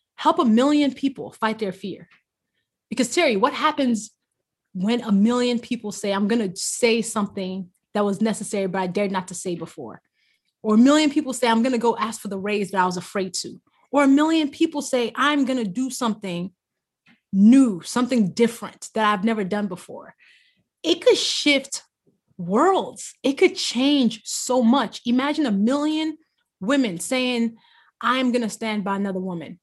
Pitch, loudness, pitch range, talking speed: 230 Hz, -22 LUFS, 205-265 Hz, 180 wpm